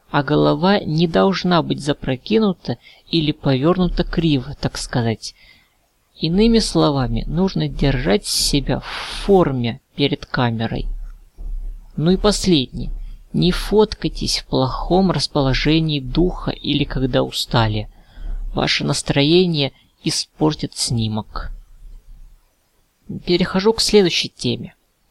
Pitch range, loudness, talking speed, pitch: 130-180 Hz, -18 LUFS, 95 wpm, 150 Hz